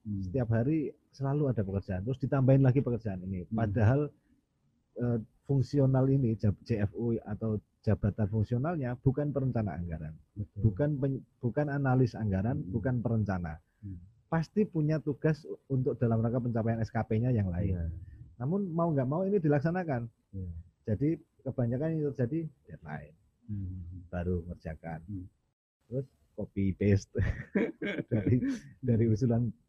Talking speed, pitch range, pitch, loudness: 115 wpm, 100-135 Hz, 115 Hz, -31 LUFS